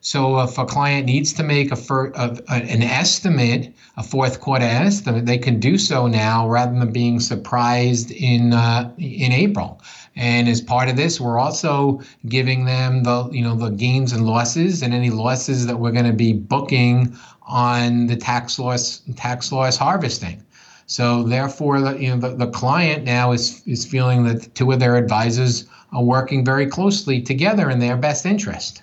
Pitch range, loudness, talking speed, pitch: 120-135 Hz, -18 LUFS, 185 wpm, 125 Hz